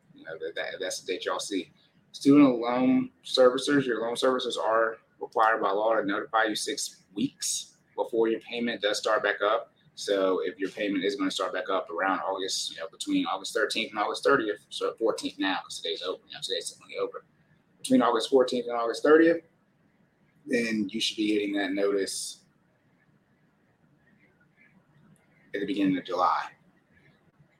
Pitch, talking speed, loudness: 140 Hz, 170 wpm, -27 LUFS